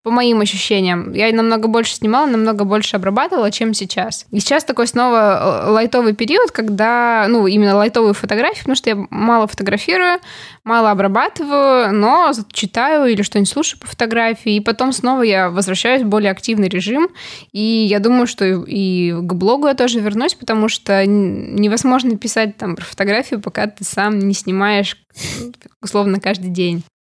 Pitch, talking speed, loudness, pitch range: 220 Hz, 160 wpm, -15 LUFS, 200-240 Hz